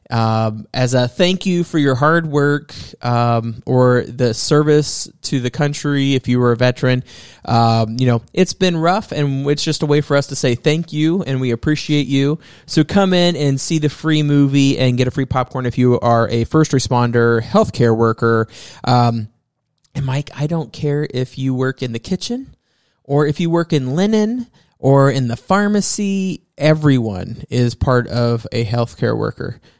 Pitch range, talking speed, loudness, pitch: 120-155 Hz, 185 wpm, -16 LUFS, 135 Hz